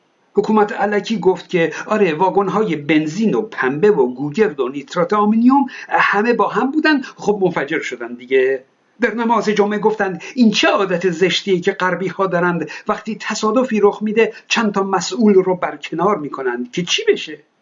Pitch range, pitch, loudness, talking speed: 175-215 Hz, 200 Hz, -17 LUFS, 160 wpm